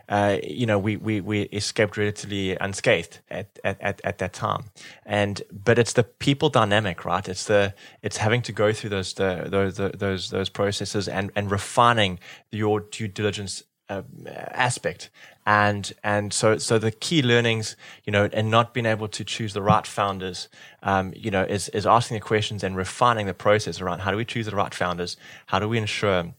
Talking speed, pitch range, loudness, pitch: 200 wpm, 100-110 Hz, -24 LUFS, 105 Hz